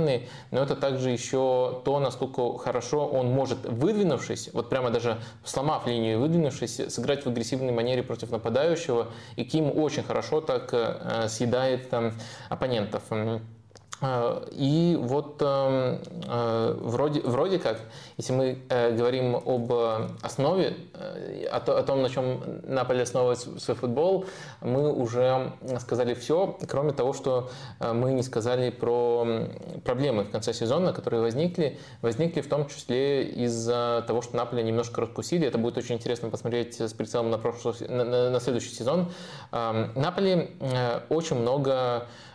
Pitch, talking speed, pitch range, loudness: 125 Hz, 135 wpm, 120-135 Hz, -28 LUFS